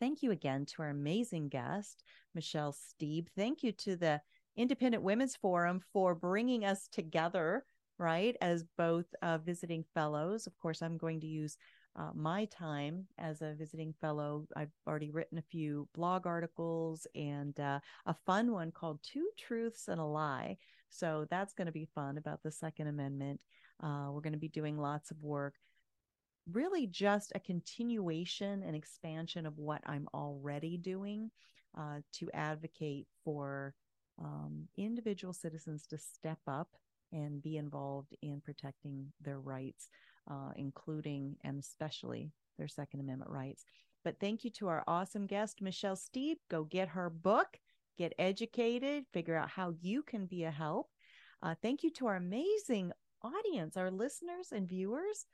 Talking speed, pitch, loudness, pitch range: 160 wpm, 165 Hz, -40 LUFS, 150-200 Hz